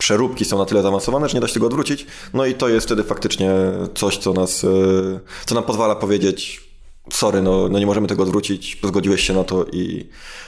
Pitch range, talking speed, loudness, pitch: 95-110 Hz, 210 wpm, -18 LUFS, 100 Hz